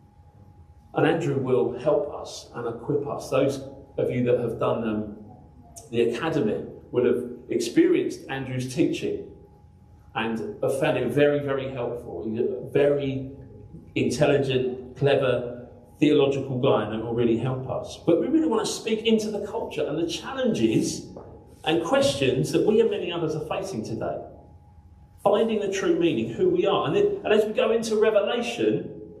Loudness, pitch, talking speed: -25 LUFS, 140 Hz, 160 wpm